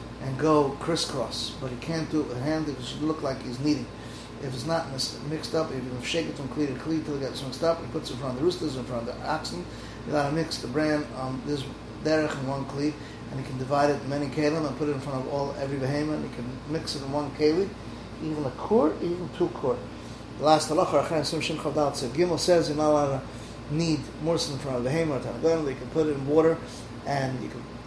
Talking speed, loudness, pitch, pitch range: 250 wpm, -28 LUFS, 145 Hz, 130-155 Hz